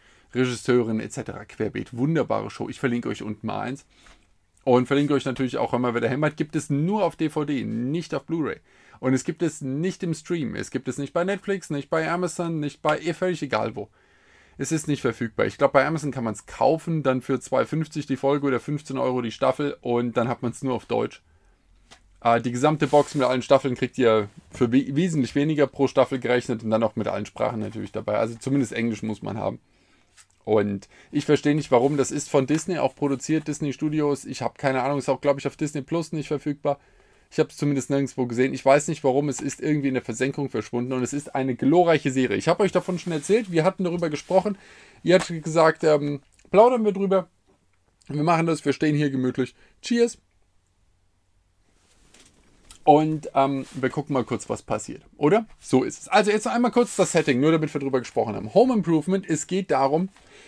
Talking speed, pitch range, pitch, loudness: 210 wpm, 125-160 Hz, 140 Hz, -24 LUFS